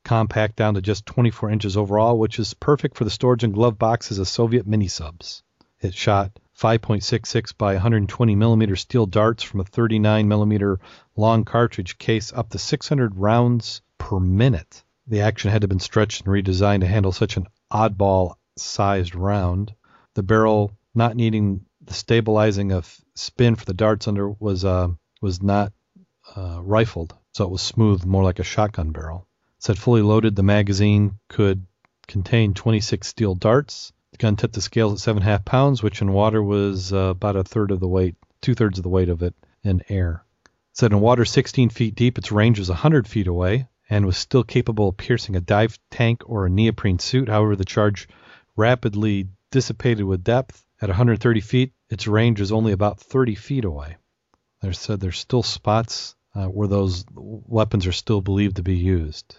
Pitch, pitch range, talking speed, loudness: 105 Hz, 95-115 Hz, 180 wpm, -21 LUFS